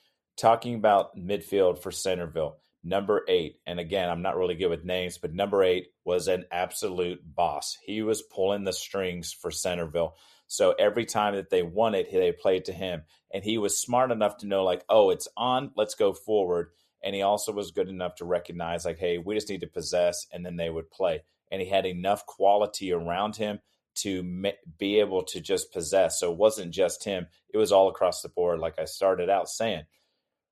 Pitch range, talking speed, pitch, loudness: 90-120 Hz, 205 wpm, 100 Hz, -28 LUFS